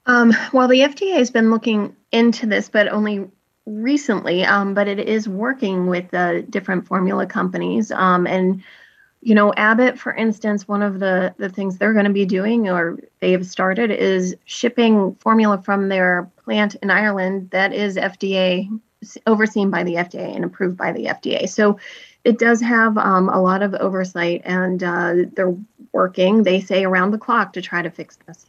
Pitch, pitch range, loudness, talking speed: 200 Hz, 185-220 Hz, -18 LUFS, 185 wpm